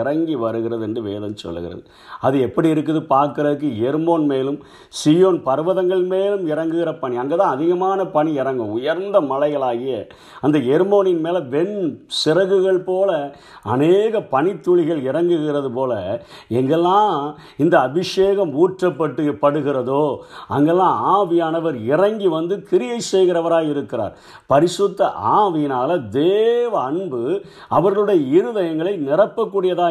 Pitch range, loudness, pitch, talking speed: 145-195 Hz, -18 LUFS, 170 Hz, 100 wpm